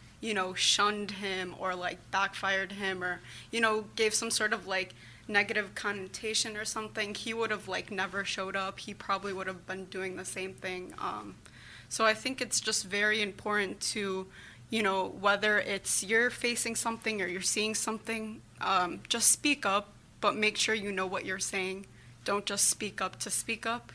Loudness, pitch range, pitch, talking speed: -31 LUFS, 190-220 Hz, 200 Hz, 190 wpm